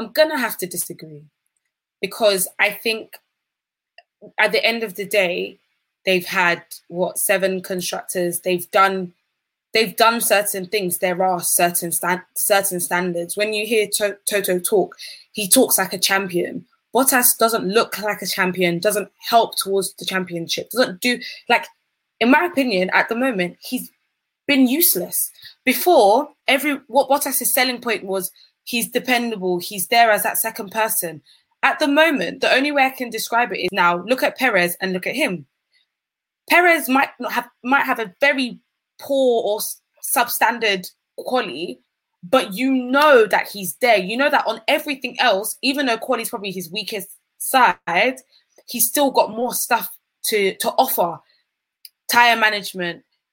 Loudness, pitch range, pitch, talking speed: -19 LUFS, 190-255 Hz, 220 Hz, 160 wpm